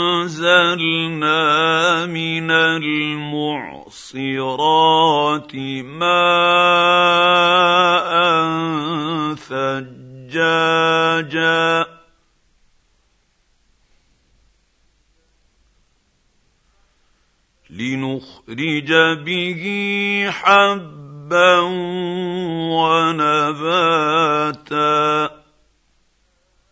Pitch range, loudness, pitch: 150-175 Hz, -16 LUFS, 165 Hz